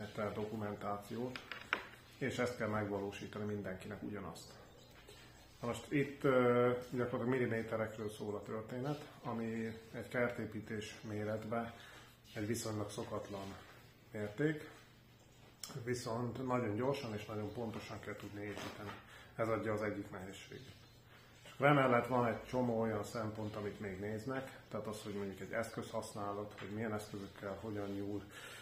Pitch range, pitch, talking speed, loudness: 105-120 Hz, 110 Hz, 125 wpm, -40 LUFS